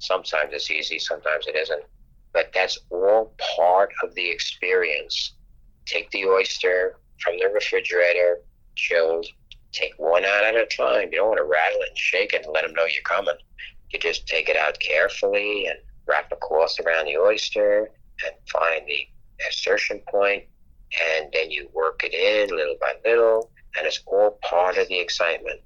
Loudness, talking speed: -22 LUFS, 175 wpm